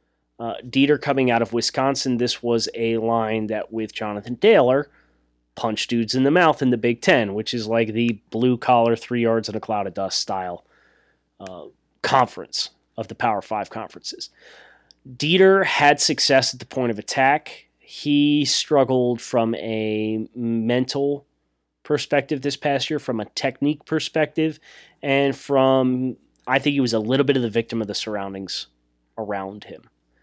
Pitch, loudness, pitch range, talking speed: 125 Hz, -21 LUFS, 110-140 Hz, 165 wpm